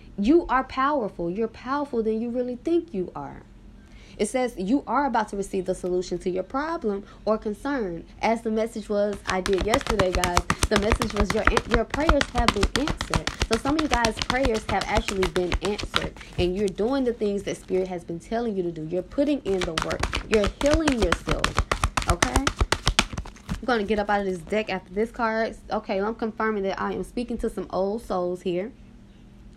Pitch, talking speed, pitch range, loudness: 215 Hz, 200 wpm, 190-240 Hz, -25 LUFS